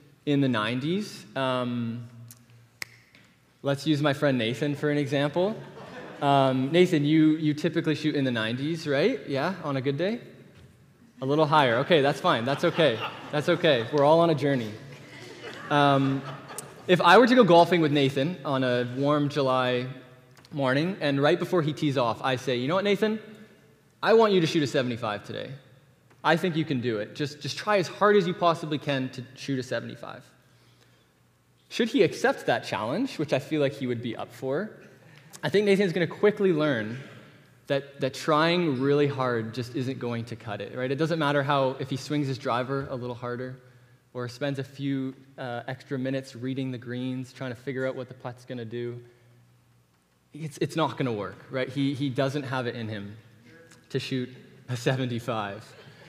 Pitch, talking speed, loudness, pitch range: 140 Hz, 190 wpm, -26 LUFS, 125-155 Hz